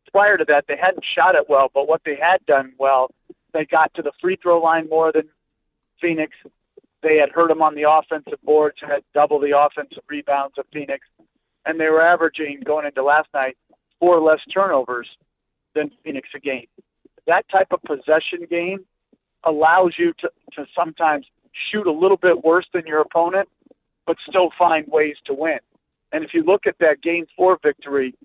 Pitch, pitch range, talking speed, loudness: 155 Hz, 145-175 Hz, 185 wpm, -19 LUFS